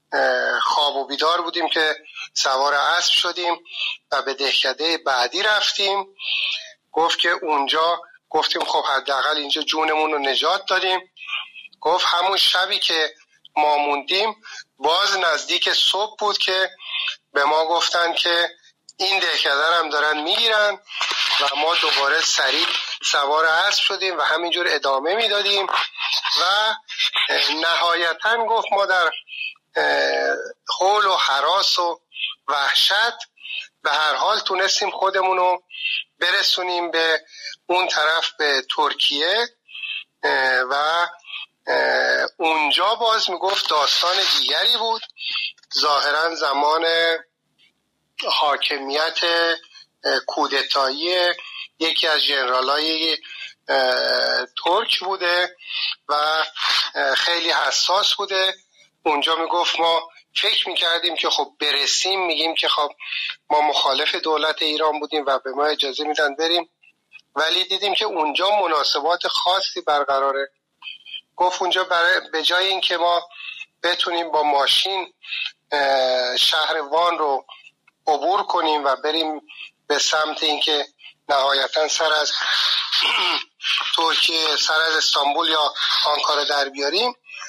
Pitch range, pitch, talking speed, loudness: 150-185 Hz, 165 Hz, 110 wpm, -19 LUFS